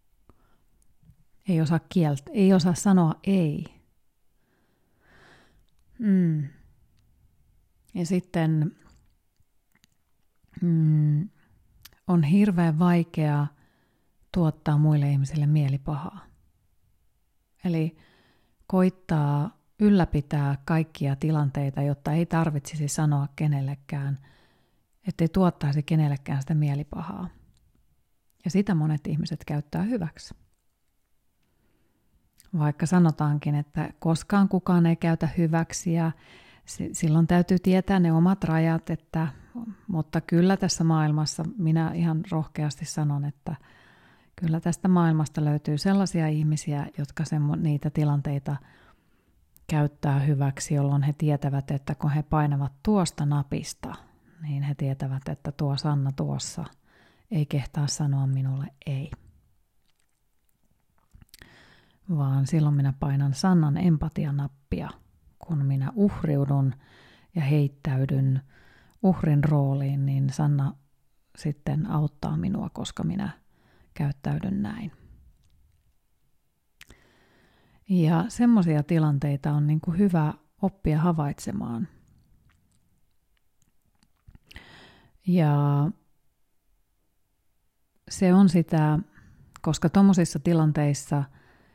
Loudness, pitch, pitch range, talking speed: -25 LUFS, 155 Hz, 140-170 Hz, 90 wpm